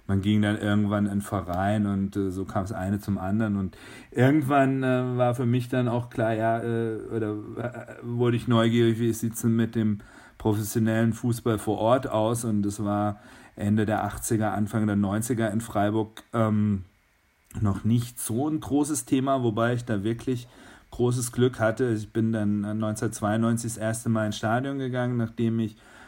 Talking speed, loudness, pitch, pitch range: 175 wpm, -26 LUFS, 110 Hz, 105-120 Hz